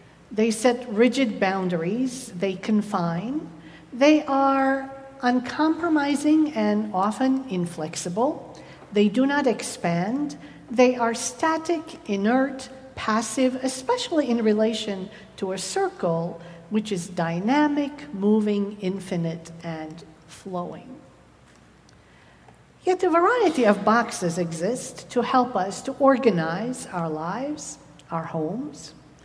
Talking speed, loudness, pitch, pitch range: 100 wpm, -24 LUFS, 225 Hz, 185-270 Hz